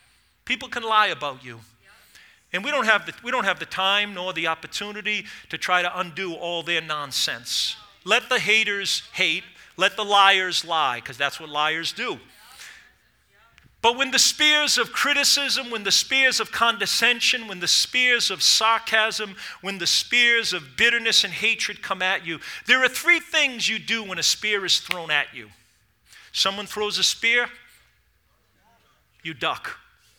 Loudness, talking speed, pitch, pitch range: -21 LUFS, 165 wpm, 210 Hz, 180-235 Hz